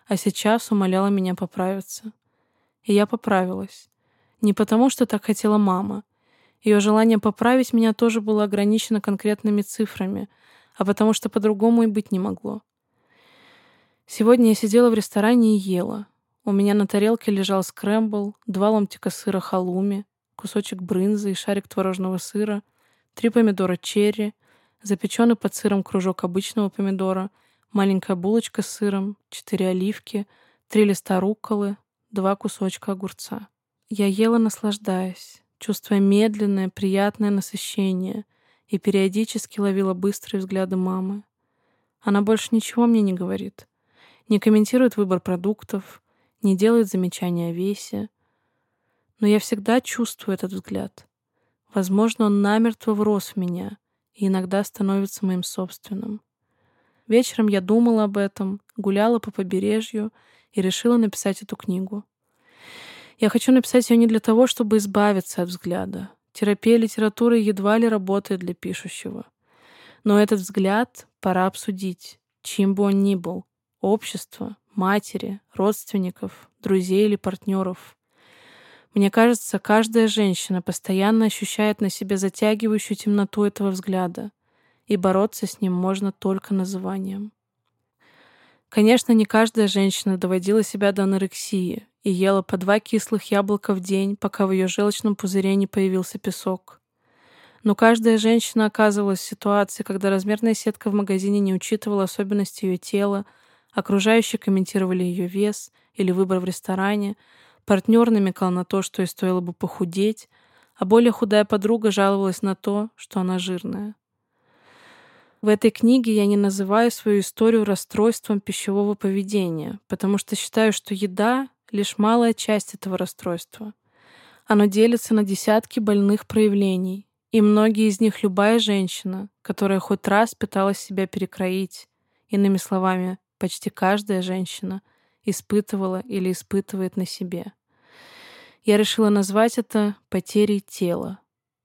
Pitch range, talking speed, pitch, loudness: 195-215 Hz, 130 wpm, 205 Hz, -22 LUFS